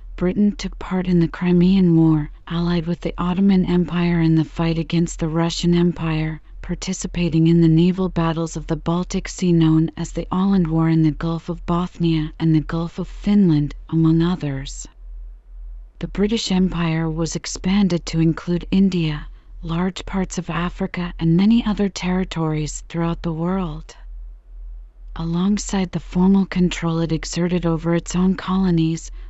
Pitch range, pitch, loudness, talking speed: 160-180 Hz, 170 Hz, -20 LUFS, 150 wpm